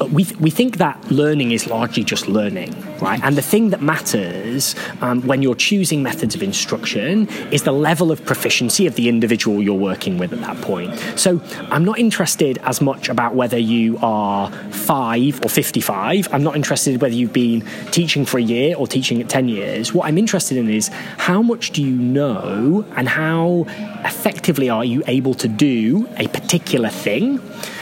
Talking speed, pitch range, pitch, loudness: 190 wpm, 120-185 Hz, 145 Hz, -18 LUFS